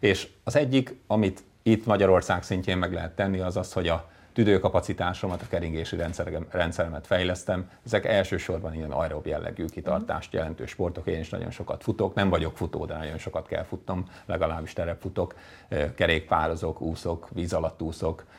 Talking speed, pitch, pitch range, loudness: 155 wpm, 90 Hz, 85-100 Hz, -28 LUFS